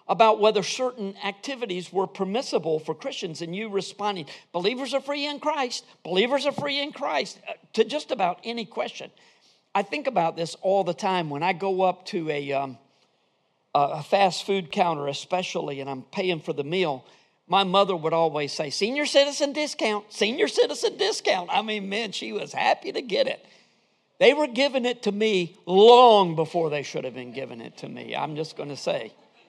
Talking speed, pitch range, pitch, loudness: 185 wpm, 165-240 Hz, 195 Hz, -24 LUFS